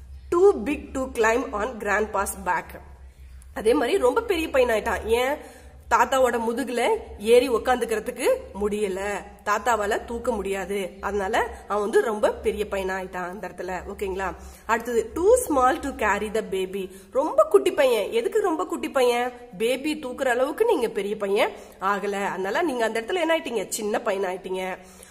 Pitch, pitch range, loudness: 230 Hz, 200-280 Hz, -24 LUFS